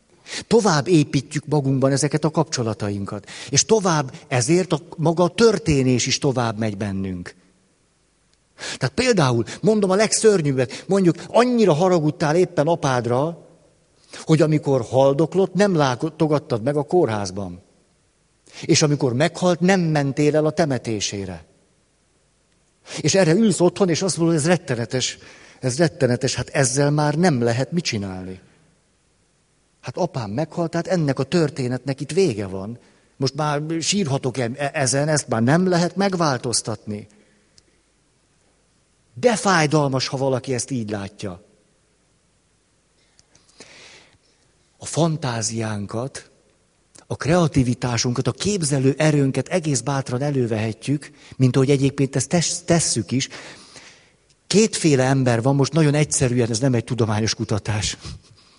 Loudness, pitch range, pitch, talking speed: -20 LUFS, 125-165 Hz, 140 Hz, 120 wpm